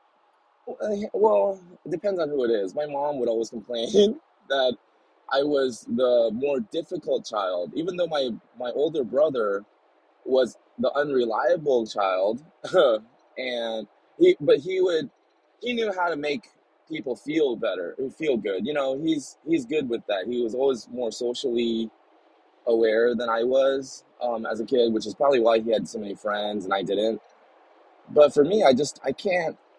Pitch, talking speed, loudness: 140 Hz, 165 wpm, -25 LUFS